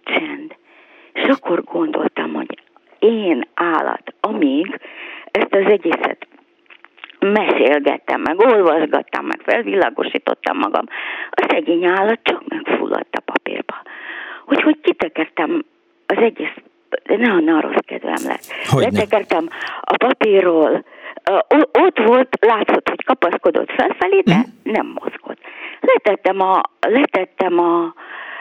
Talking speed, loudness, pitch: 105 wpm, -17 LUFS, 310 Hz